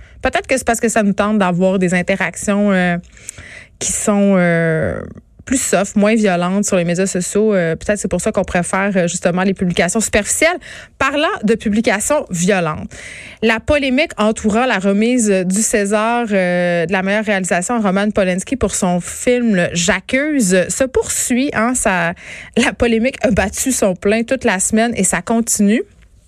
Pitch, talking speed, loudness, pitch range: 210 Hz, 165 wpm, -15 LUFS, 185-230 Hz